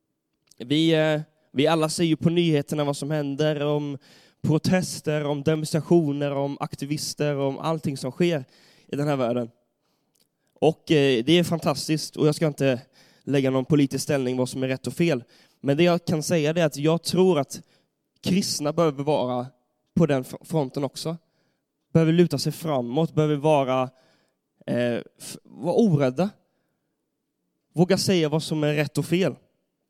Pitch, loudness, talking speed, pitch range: 150 Hz, -24 LUFS, 155 wpm, 140-160 Hz